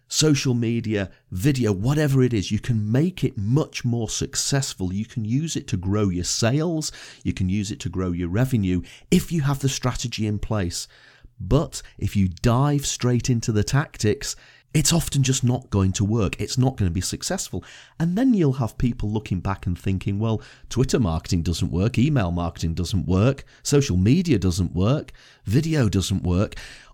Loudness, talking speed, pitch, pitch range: -23 LUFS, 185 wpm, 115 Hz, 95-135 Hz